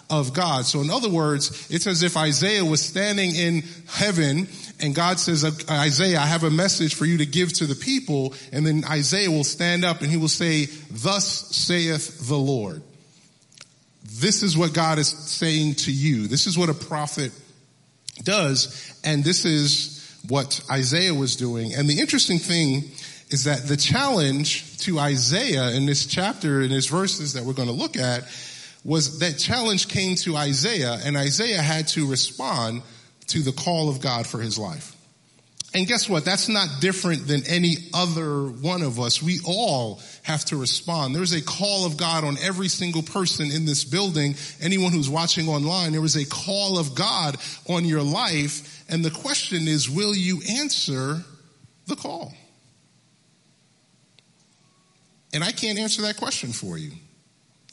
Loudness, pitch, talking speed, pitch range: -22 LUFS, 155 Hz, 170 wpm, 145-175 Hz